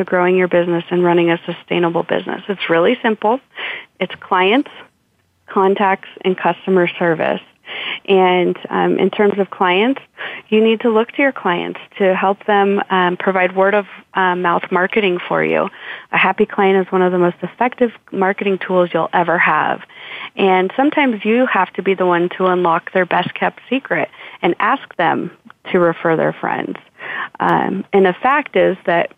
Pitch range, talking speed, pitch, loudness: 180-215 Hz, 170 wpm, 190 Hz, -16 LUFS